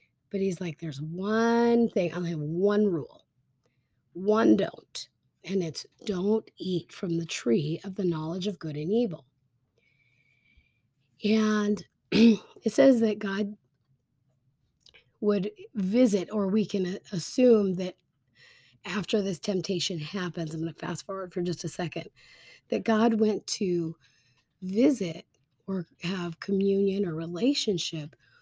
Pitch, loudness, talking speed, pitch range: 180 Hz, -28 LUFS, 130 wpm, 155-205 Hz